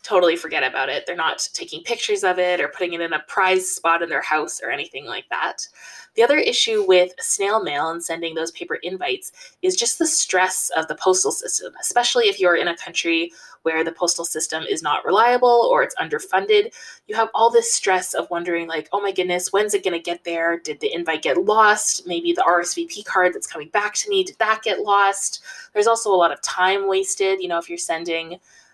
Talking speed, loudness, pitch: 220 wpm, -20 LUFS, 195 Hz